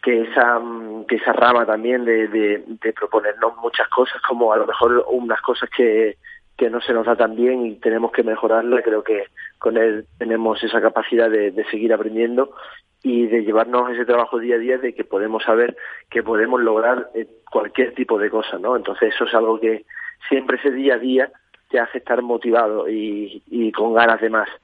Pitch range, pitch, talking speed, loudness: 110-125 Hz, 115 Hz, 195 wpm, -19 LUFS